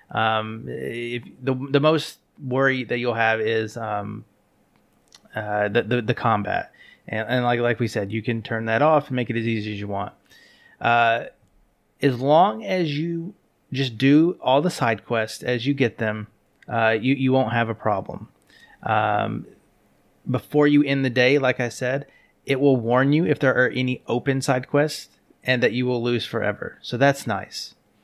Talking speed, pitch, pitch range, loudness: 185 wpm, 120 Hz, 110-135 Hz, -22 LUFS